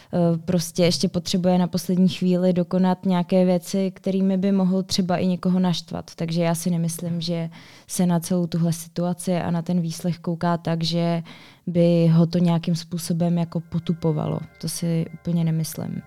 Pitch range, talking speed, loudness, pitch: 170-185 Hz, 165 wpm, -23 LUFS, 175 Hz